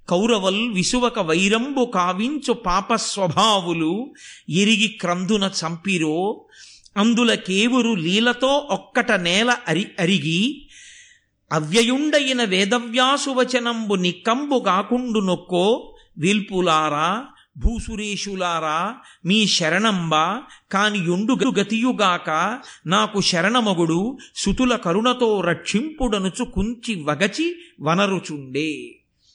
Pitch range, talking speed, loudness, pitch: 180-245 Hz, 70 wpm, -20 LUFS, 210 Hz